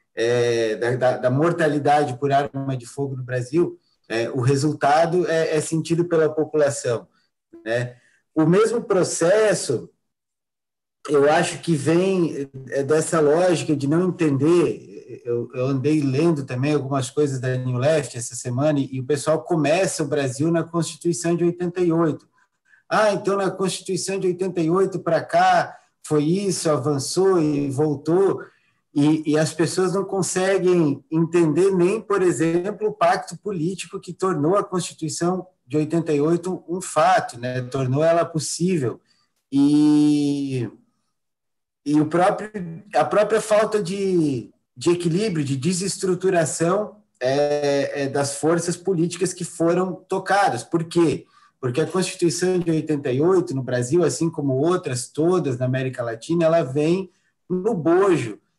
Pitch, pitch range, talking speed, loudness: 165 Hz, 140-180 Hz, 135 wpm, -21 LUFS